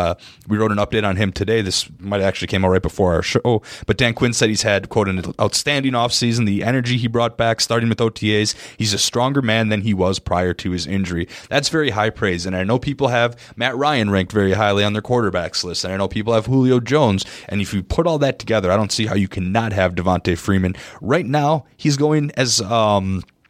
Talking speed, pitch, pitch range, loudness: 245 wpm, 110 Hz, 95-120 Hz, -18 LUFS